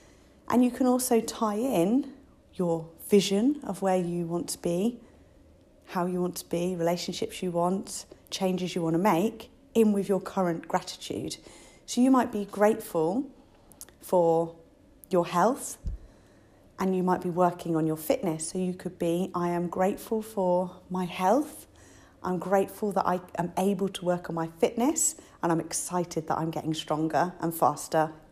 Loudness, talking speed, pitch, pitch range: -28 LUFS, 165 wpm, 180 Hz, 170-210 Hz